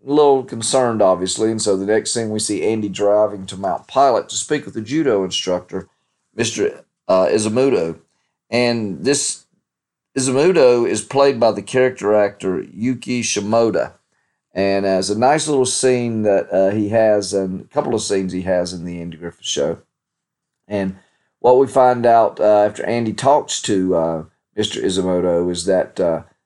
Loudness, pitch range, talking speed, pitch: -17 LUFS, 95-125 Hz, 170 wpm, 105 Hz